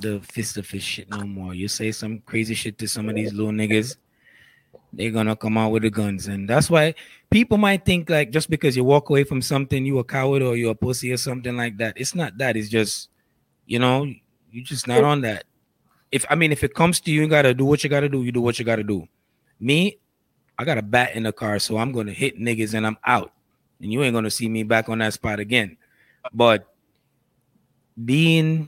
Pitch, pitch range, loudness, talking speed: 120 Hz, 110-140 Hz, -21 LUFS, 235 wpm